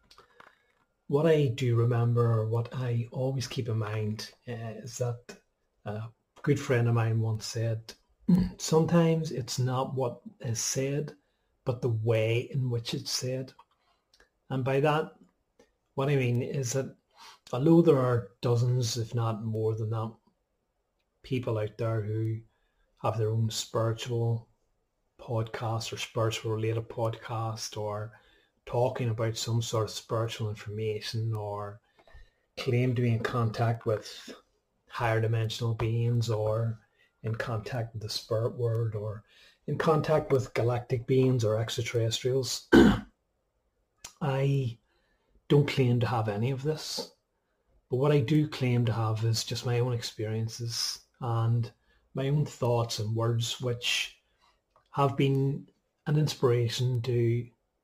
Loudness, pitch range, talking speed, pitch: -29 LUFS, 110-130 Hz, 130 wpm, 120 Hz